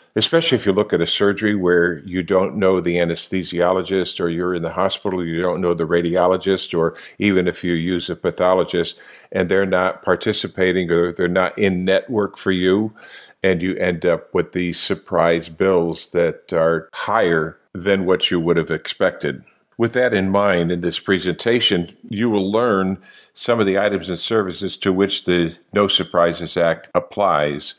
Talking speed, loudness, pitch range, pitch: 175 wpm, -19 LUFS, 85-95 Hz, 90 Hz